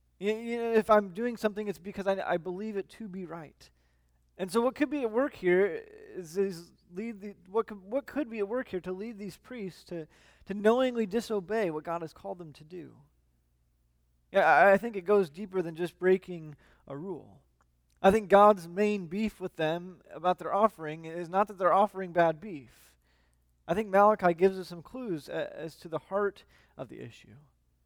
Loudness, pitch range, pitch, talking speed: -29 LUFS, 165-215 Hz, 190 Hz, 200 wpm